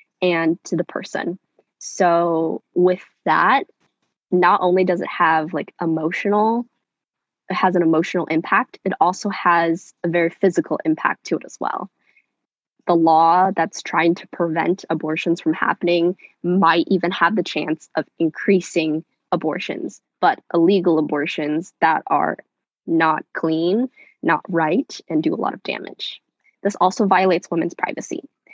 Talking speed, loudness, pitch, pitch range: 140 wpm, -20 LUFS, 170 Hz, 165-185 Hz